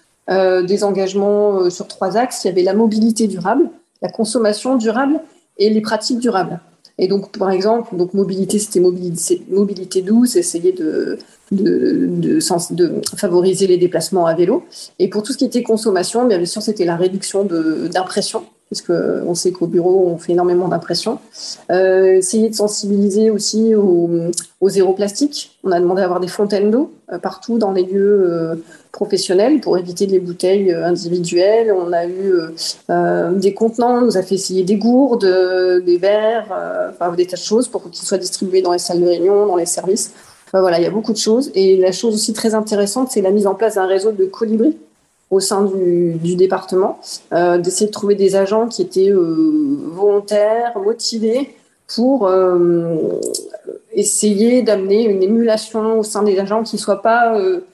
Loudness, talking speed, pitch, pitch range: -16 LUFS, 185 wpm, 200 Hz, 185-225 Hz